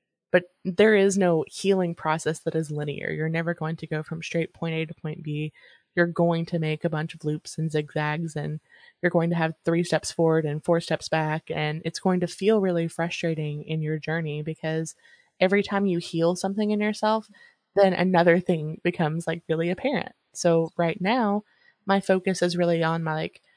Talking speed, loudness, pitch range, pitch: 200 wpm, -25 LUFS, 160-180 Hz, 165 Hz